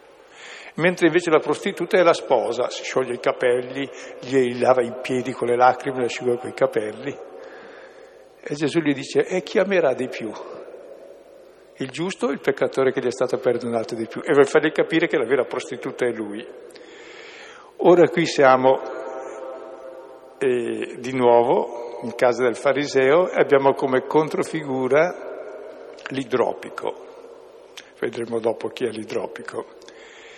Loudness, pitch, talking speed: -21 LUFS, 165 Hz, 145 wpm